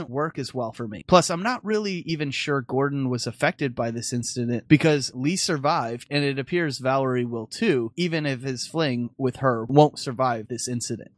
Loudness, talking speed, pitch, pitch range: -24 LUFS, 195 wpm, 135 Hz, 120-155 Hz